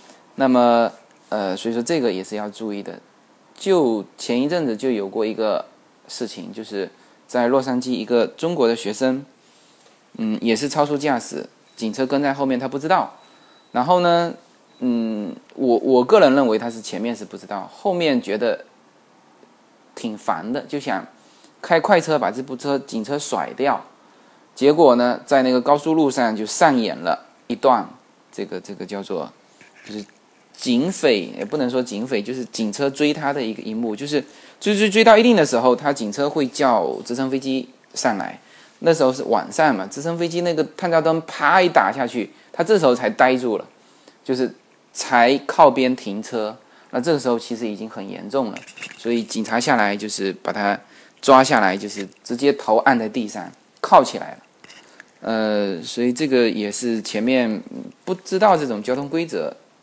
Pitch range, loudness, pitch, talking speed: 110-145 Hz, -20 LUFS, 125 Hz, 255 characters per minute